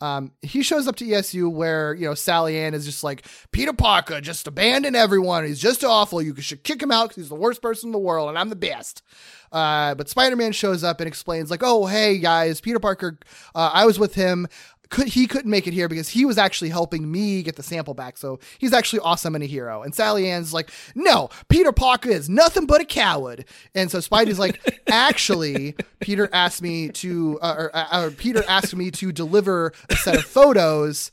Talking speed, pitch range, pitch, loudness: 215 wpm, 160-220 Hz, 180 Hz, -20 LUFS